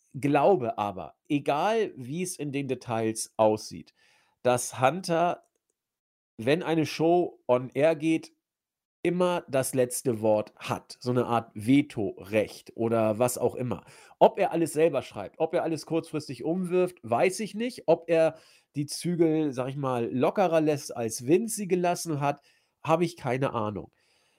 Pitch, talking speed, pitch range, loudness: 145 Hz, 150 wpm, 125-165 Hz, -27 LUFS